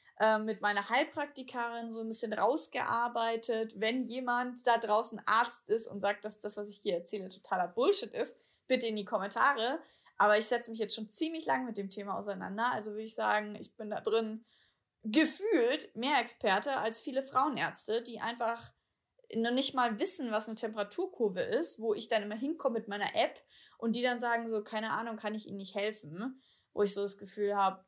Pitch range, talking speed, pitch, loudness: 210-250 Hz, 195 wpm, 225 Hz, -32 LUFS